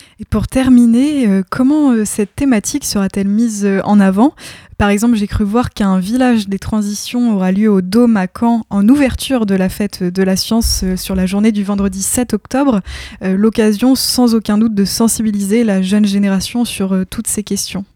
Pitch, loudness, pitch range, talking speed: 210 Hz, -13 LUFS, 195-235 Hz, 195 wpm